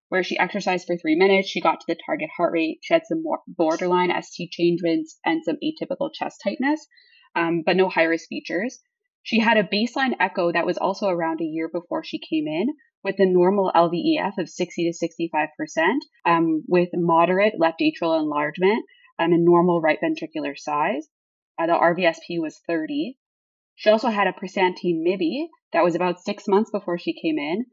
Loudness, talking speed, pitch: -22 LUFS, 190 wpm, 185 Hz